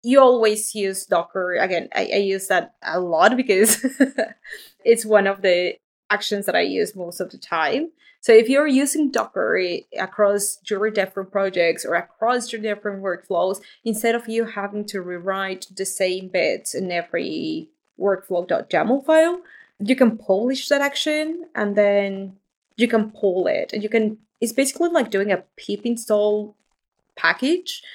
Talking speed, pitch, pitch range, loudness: 155 wpm, 210 Hz, 195-255 Hz, -21 LUFS